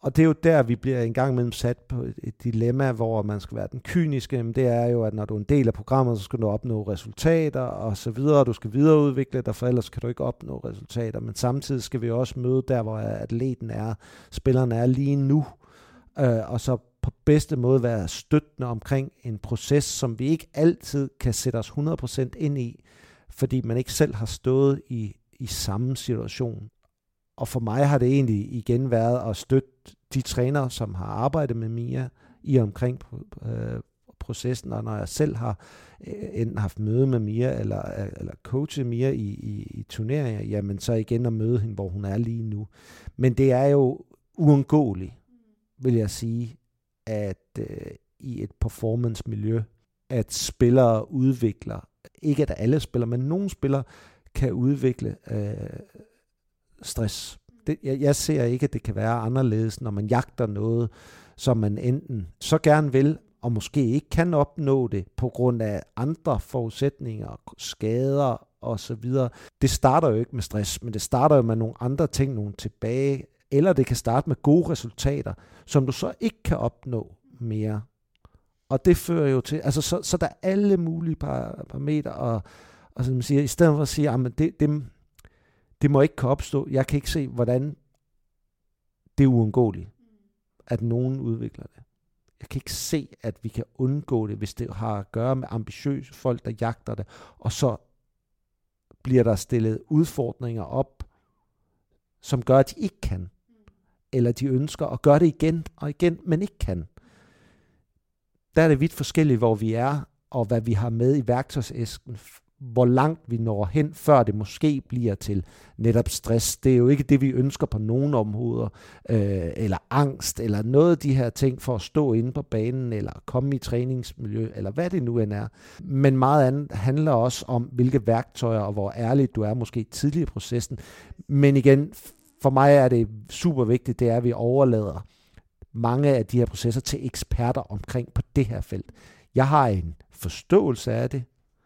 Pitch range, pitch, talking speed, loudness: 110-140 Hz, 125 Hz, 185 wpm, -24 LUFS